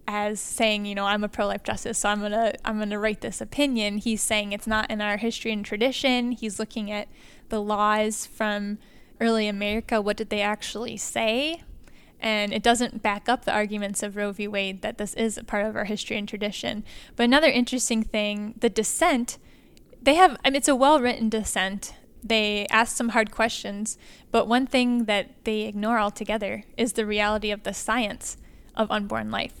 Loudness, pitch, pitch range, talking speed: -25 LUFS, 220 Hz, 210-235 Hz, 195 wpm